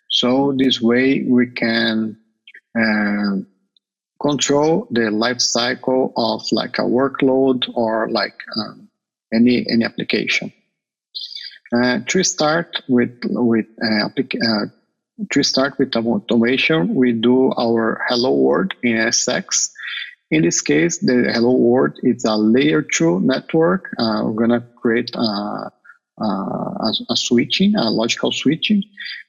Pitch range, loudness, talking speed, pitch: 115-135 Hz, -17 LUFS, 125 wpm, 120 Hz